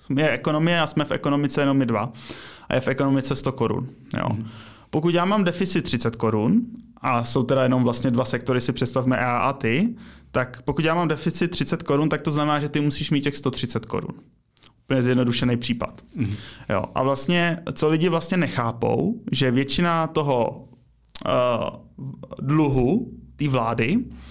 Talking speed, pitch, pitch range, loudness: 165 wpm, 135 Hz, 125-155 Hz, -22 LUFS